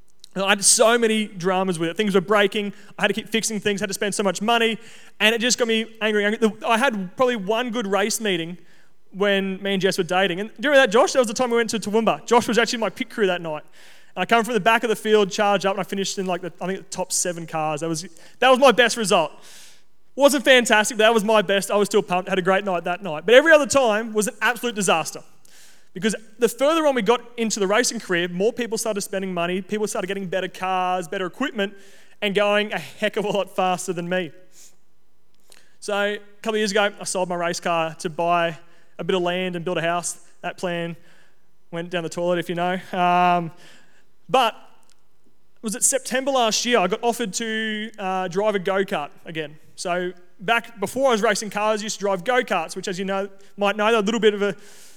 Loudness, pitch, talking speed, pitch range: -21 LUFS, 200 Hz, 245 wpm, 185-225 Hz